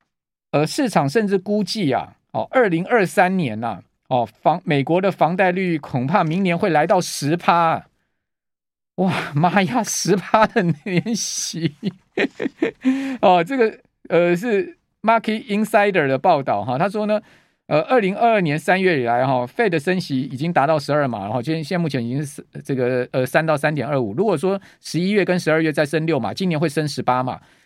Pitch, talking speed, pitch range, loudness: 170 Hz, 280 characters per minute, 150-200 Hz, -20 LUFS